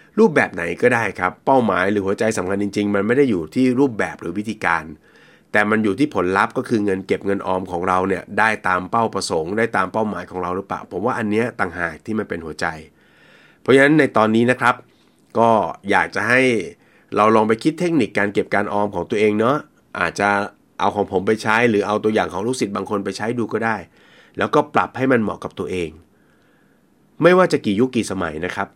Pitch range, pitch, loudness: 95-115 Hz, 105 Hz, -19 LUFS